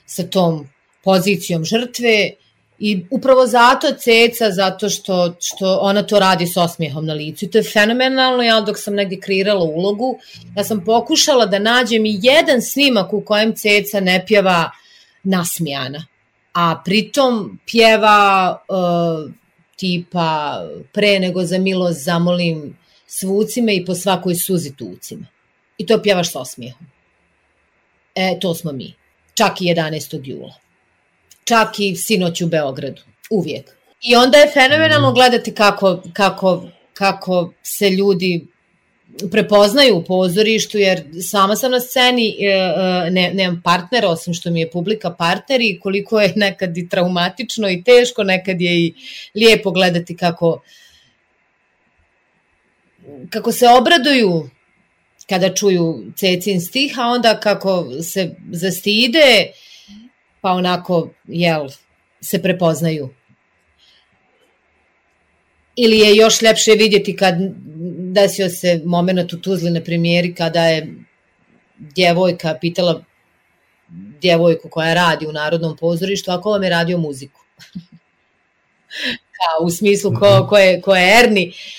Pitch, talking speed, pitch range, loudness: 190 Hz, 125 wpm, 170-215 Hz, -15 LUFS